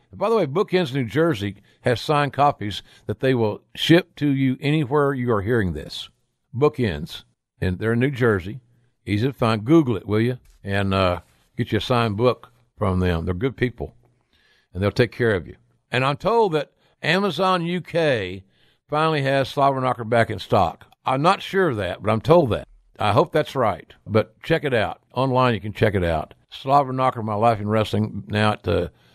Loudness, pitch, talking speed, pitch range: -22 LUFS, 120 Hz, 195 wpm, 105-140 Hz